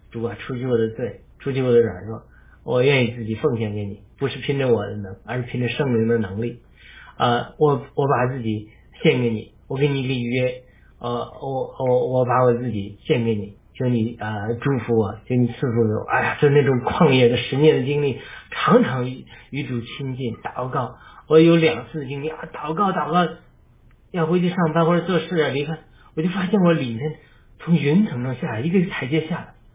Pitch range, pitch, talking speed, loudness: 115-155 Hz, 130 Hz, 290 characters per minute, -21 LUFS